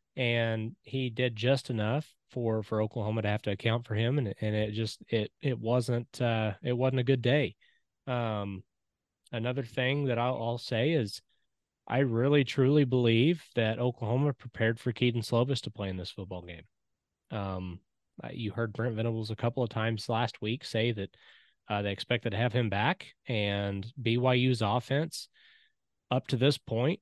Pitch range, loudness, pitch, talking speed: 110-130 Hz, -31 LUFS, 120 Hz, 175 wpm